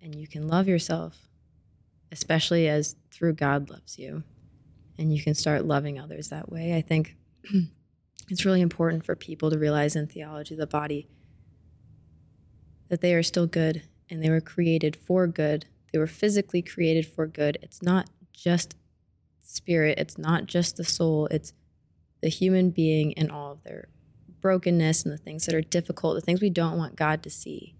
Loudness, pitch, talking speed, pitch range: -26 LUFS, 160 Hz, 175 wpm, 150-170 Hz